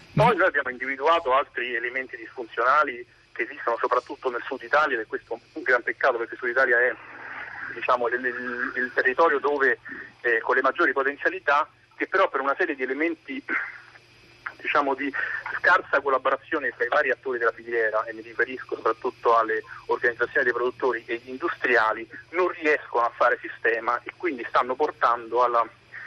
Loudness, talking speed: -24 LUFS, 165 wpm